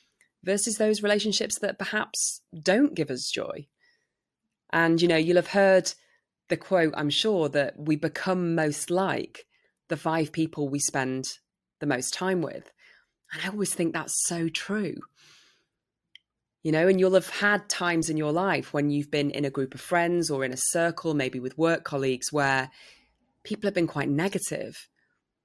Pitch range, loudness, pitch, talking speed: 145-190 Hz, -26 LUFS, 165 Hz, 170 wpm